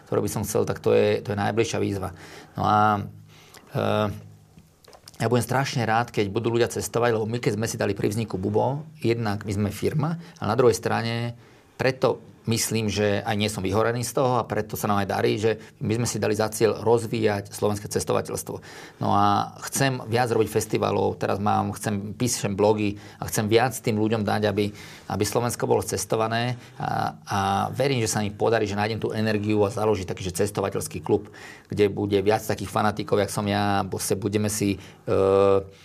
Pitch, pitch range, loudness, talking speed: 105 Hz, 100-115 Hz, -24 LUFS, 195 wpm